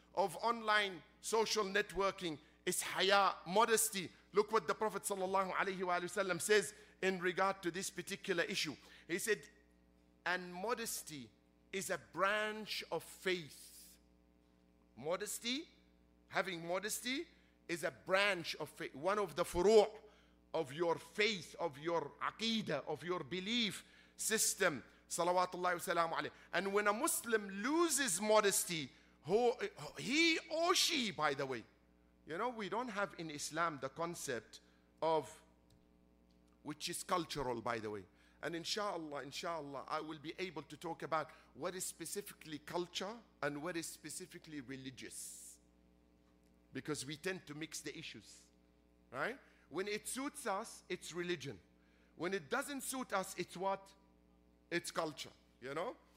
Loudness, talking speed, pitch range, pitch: -39 LUFS, 130 wpm, 135-200 Hz, 175 Hz